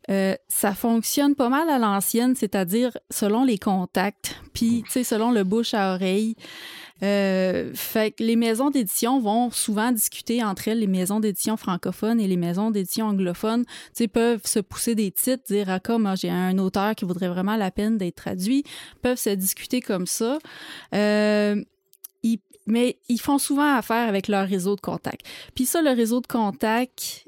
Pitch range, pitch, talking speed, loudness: 195-240 Hz, 220 Hz, 180 wpm, -23 LUFS